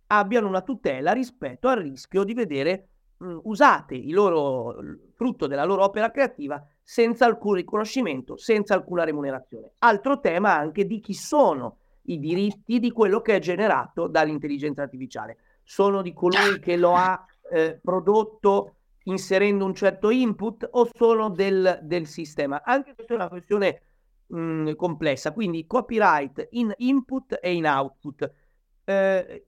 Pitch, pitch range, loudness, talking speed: 195 Hz, 170-230 Hz, -23 LUFS, 145 wpm